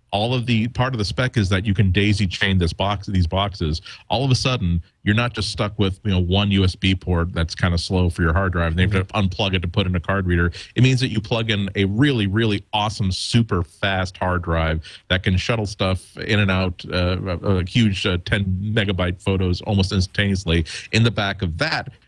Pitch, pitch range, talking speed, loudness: 95 Hz, 90-105 Hz, 230 wpm, -21 LUFS